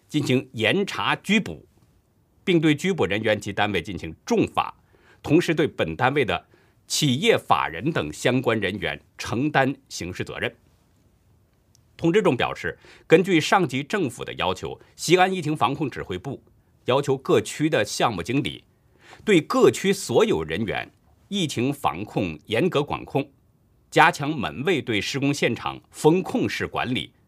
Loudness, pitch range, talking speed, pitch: -23 LUFS, 105-165 Hz, 225 characters per minute, 140 Hz